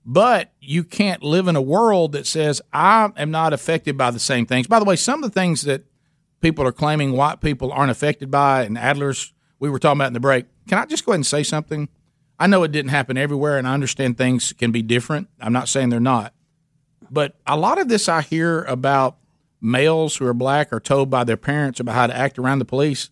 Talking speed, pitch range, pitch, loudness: 240 wpm, 130-160 Hz, 145 Hz, -19 LUFS